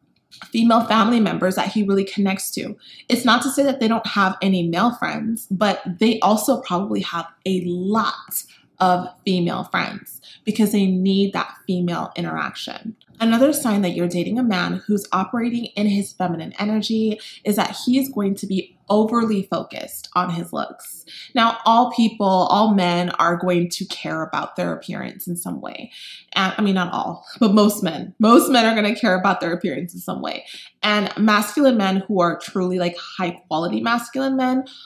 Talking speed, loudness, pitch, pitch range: 180 wpm, -20 LUFS, 200 Hz, 180-225 Hz